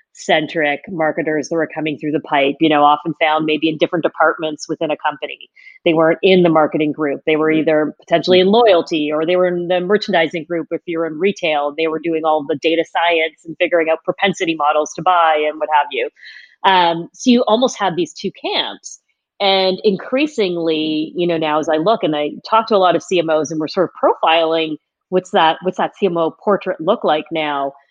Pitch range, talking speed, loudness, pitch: 155-185 Hz, 210 wpm, -16 LUFS, 165 Hz